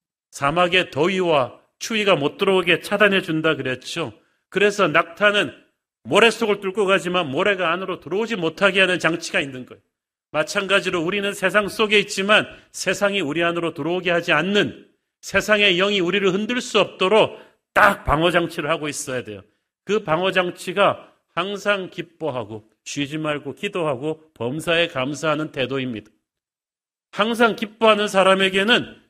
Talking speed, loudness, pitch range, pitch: 330 characters per minute, -20 LUFS, 155-200 Hz, 180 Hz